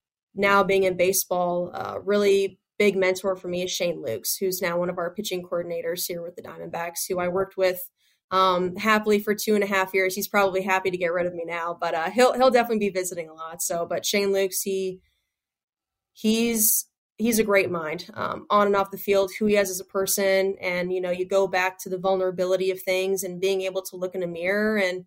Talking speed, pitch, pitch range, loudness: 230 wpm, 190 Hz, 180-200 Hz, -24 LUFS